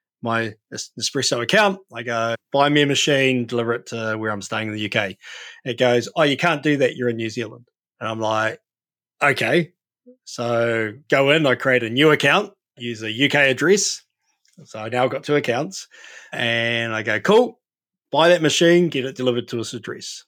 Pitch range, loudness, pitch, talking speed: 115-145 Hz, -19 LUFS, 125 Hz, 190 wpm